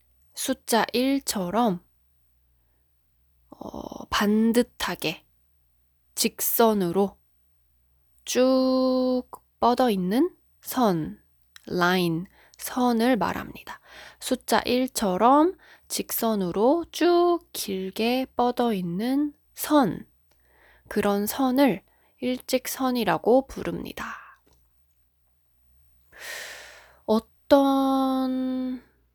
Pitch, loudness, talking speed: 225 Hz, -24 LUFS, 120 characters per minute